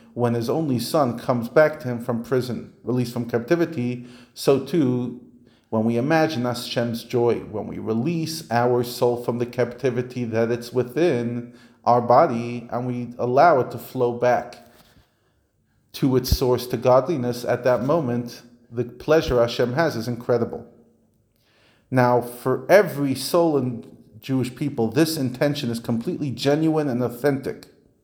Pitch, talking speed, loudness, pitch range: 120 Hz, 145 wpm, -22 LUFS, 120-130 Hz